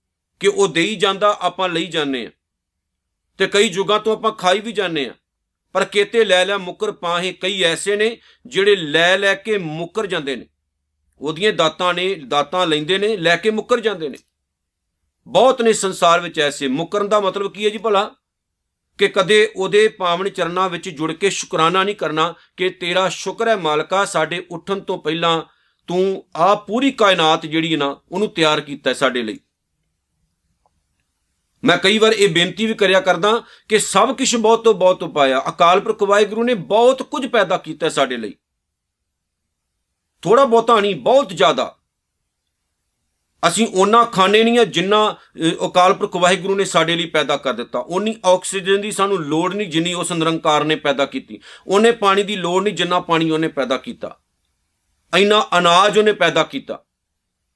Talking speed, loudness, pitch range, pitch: 165 wpm, -17 LUFS, 145-205 Hz, 180 Hz